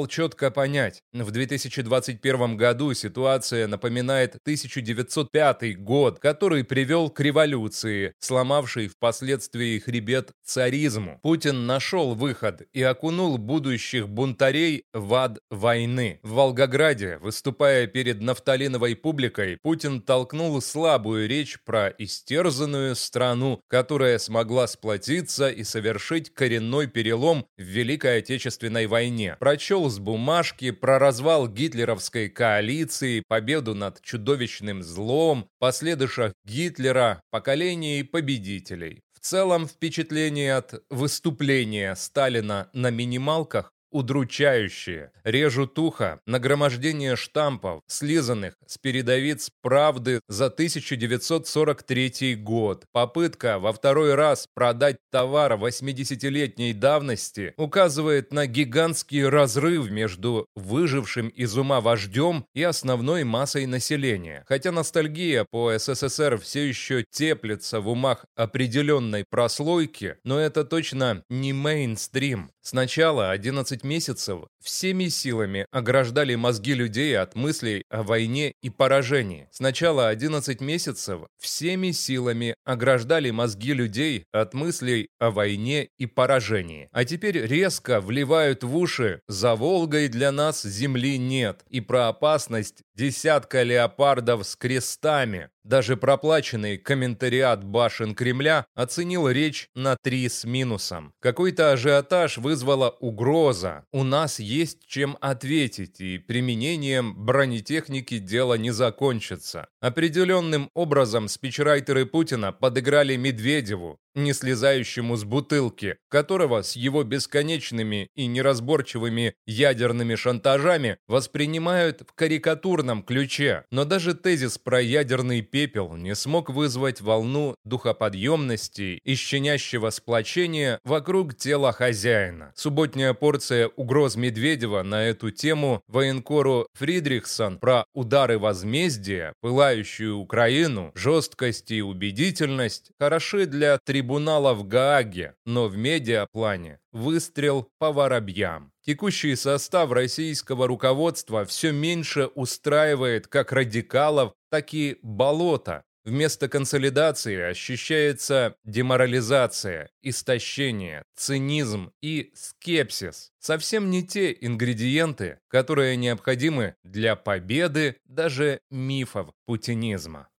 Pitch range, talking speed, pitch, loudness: 115-150 Hz, 105 wpm, 130 Hz, -24 LUFS